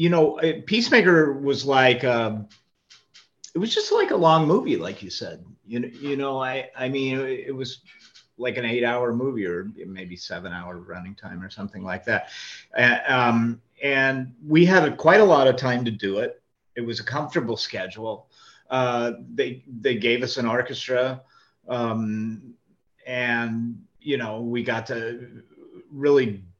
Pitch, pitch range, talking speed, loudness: 125 Hz, 115-140 Hz, 165 wpm, -22 LUFS